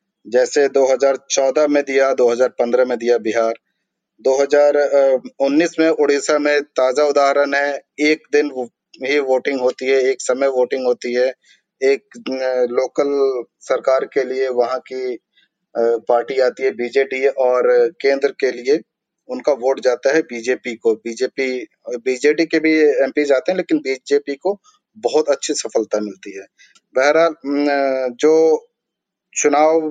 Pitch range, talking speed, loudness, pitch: 130-150 Hz, 130 wpm, -17 LUFS, 140 Hz